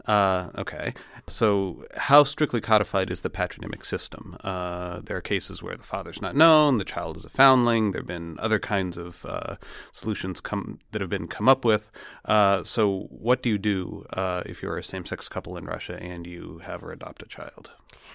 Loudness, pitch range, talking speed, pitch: -25 LUFS, 90-110 Hz, 200 wpm, 100 Hz